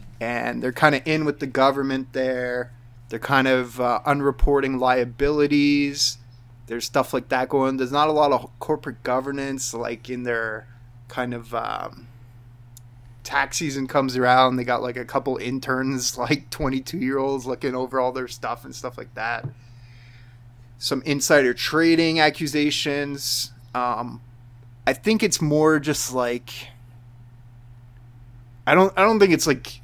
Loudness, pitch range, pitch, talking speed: -22 LUFS, 120-140 Hz, 125 Hz, 150 wpm